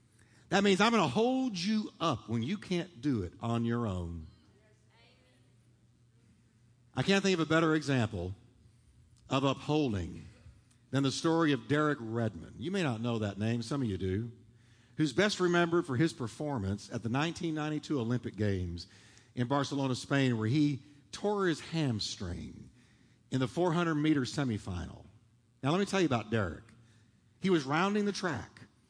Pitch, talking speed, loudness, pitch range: 125 Hz, 160 wpm, -32 LUFS, 115-155 Hz